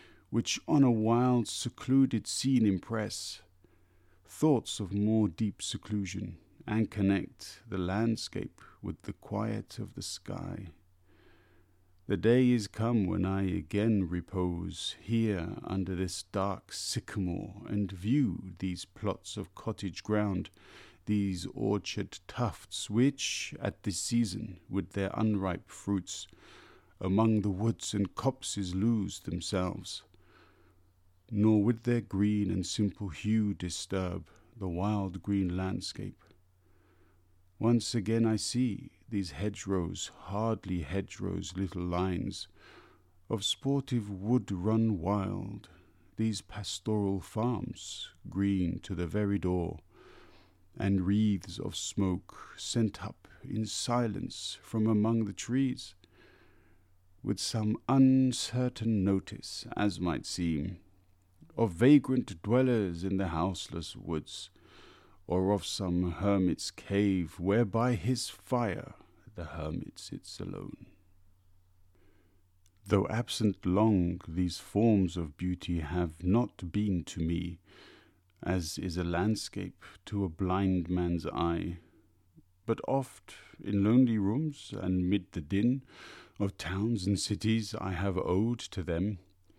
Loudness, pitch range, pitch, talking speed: -32 LUFS, 90-110 Hz, 100 Hz, 115 wpm